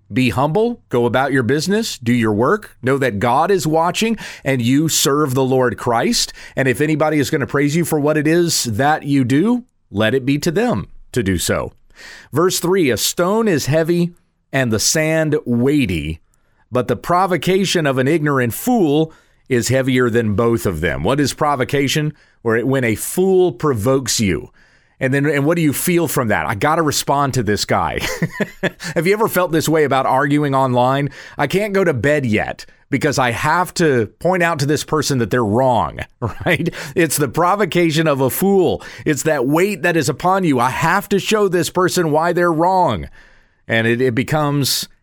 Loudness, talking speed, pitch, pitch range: -17 LUFS, 195 wpm, 145 Hz, 125-170 Hz